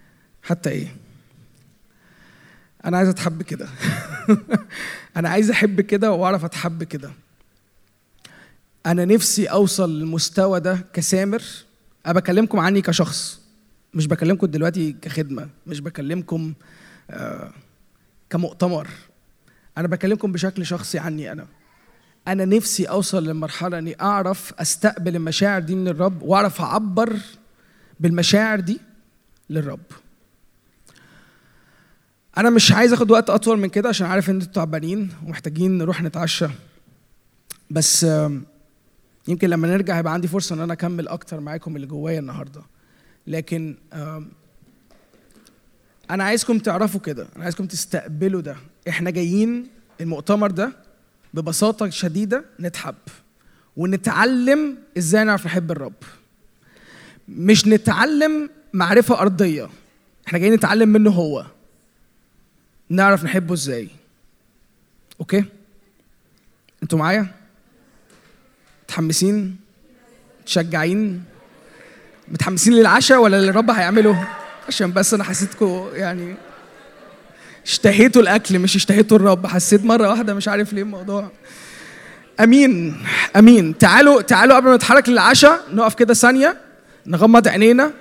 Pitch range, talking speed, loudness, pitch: 165-215 Hz, 105 wpm, -17 LUFS, 190 Hz